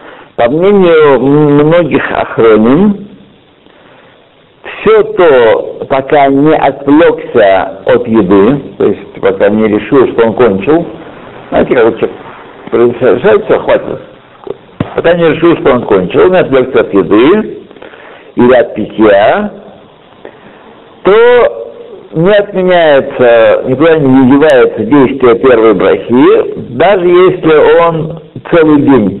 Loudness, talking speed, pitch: -7 LUFS, 100 wpm, 170 Hz